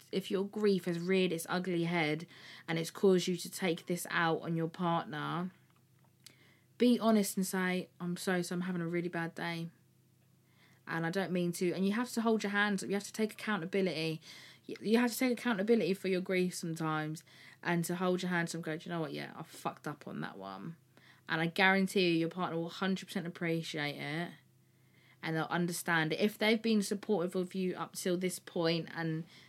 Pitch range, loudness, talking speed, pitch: 165-195 Hz, -34 LUFS, 210 wpm, 180 Hz